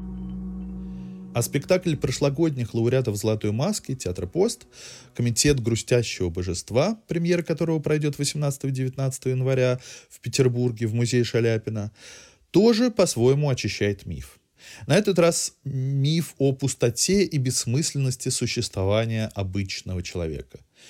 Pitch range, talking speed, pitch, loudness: 115-155 Hz, 105 wpm, 130 Hz, -24 LUFS